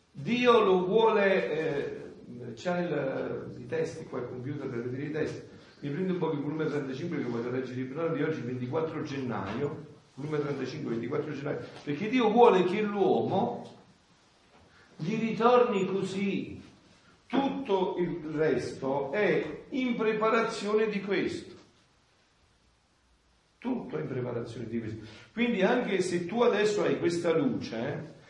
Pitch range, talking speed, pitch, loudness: 145-215 Hz, 135 wpm, 165 Hz, -29 LUFS